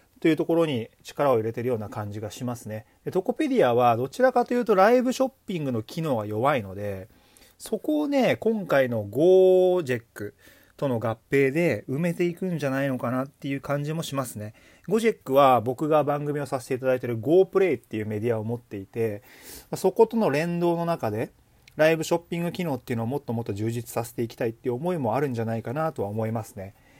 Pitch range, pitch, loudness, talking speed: 115-170 Hz, 135 Hz, -25 LUFS, 450 characters per minute